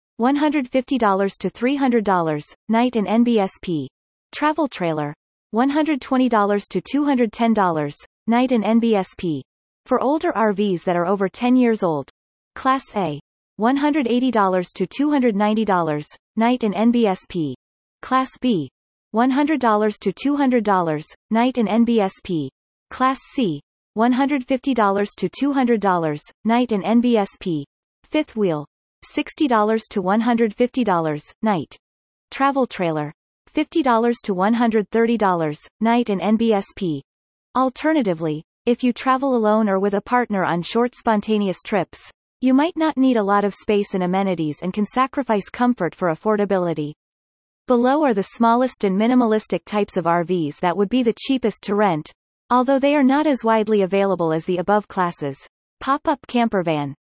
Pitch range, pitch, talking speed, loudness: 185-250 Hz, 215 Hz, 125 wpm, -20 LUFS